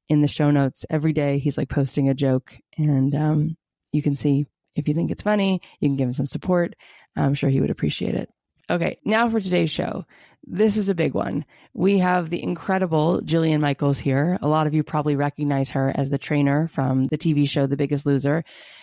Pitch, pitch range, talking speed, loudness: 150 Hz, 140-165 Hz, 215 wpm, -22 LUFS